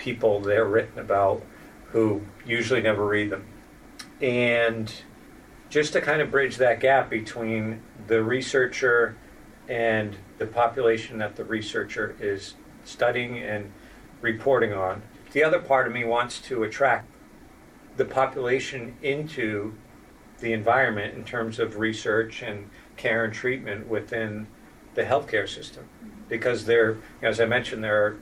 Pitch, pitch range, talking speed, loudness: 115 Hz, 105-120 Hz, 135 wpm, -25 LUFS